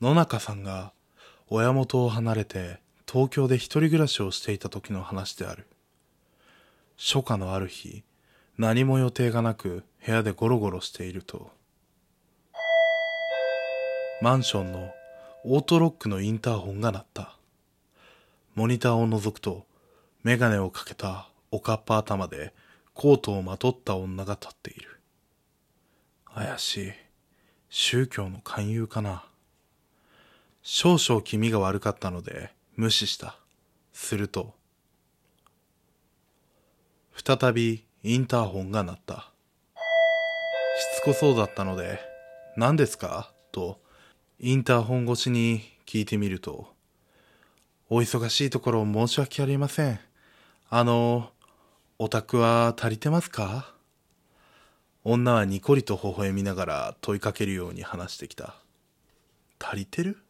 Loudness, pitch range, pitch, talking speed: -26 LUFS, 100-130 Hz, 115 Hz, 240 characters per minute